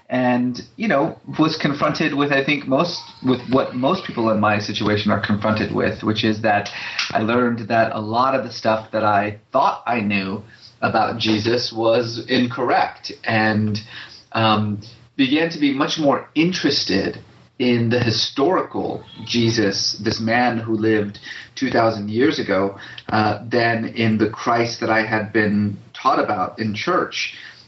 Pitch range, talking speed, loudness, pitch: 110-125 Hz, 155 wpm, -20 LUFS, 115 Hz